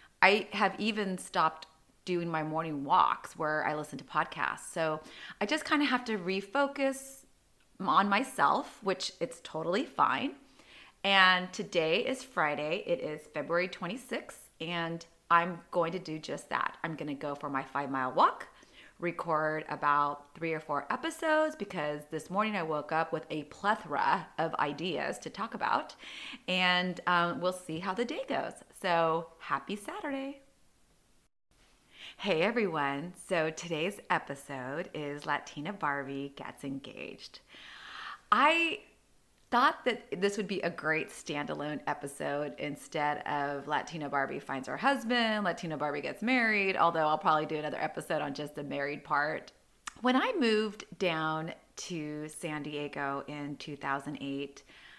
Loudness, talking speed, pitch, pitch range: -32 LUFS, 145 wpm, 165 Hz, 150-205 Hz